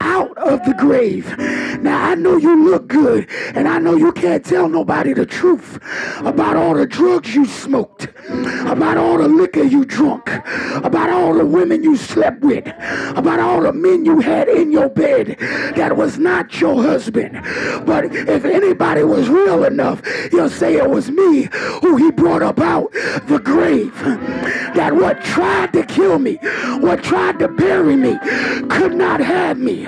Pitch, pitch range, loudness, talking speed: 330 Hz, 285-360 Hz, -15 LUFS, 170 wpm